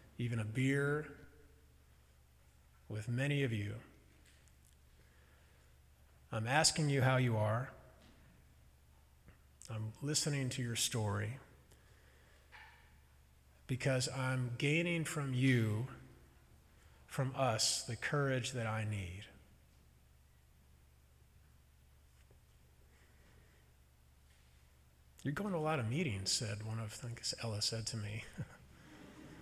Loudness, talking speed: -37 LUFS, 95 wpm